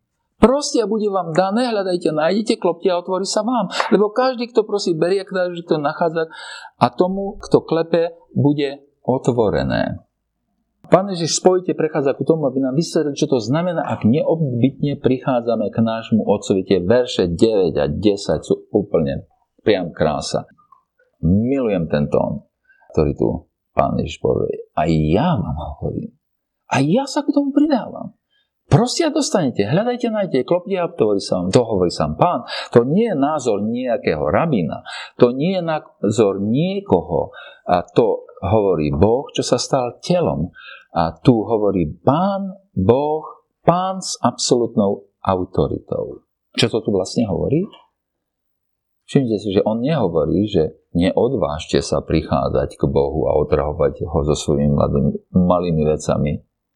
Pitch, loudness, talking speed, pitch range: 170 Hz, -19 LUFS, 145 wpm, 130-215 Hz